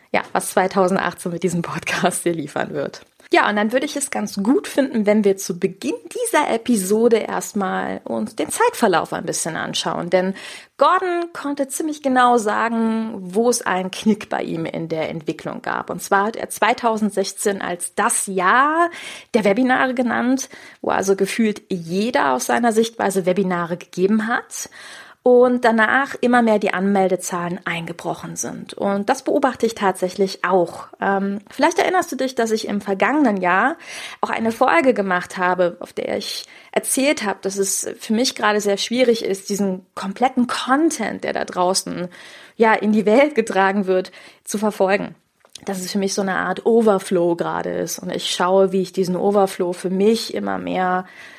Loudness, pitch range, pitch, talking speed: -19 LUFS, 185-245 Hz, 205 Hz, 170 wpm